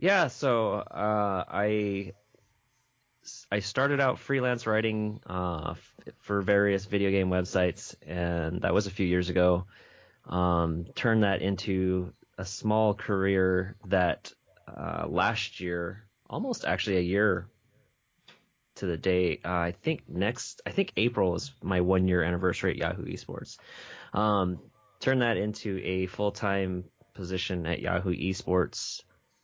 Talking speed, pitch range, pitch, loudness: 135 wpm, 90-105 Hz, 95 Hz, -29 LUFS